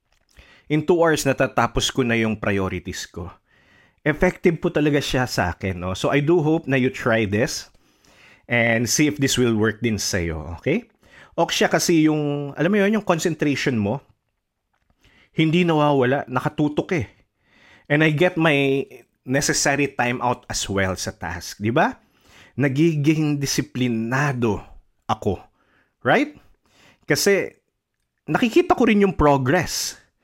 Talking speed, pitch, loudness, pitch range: 135 wpm, 135 Hz, -21 LUFS, 110-155 Hz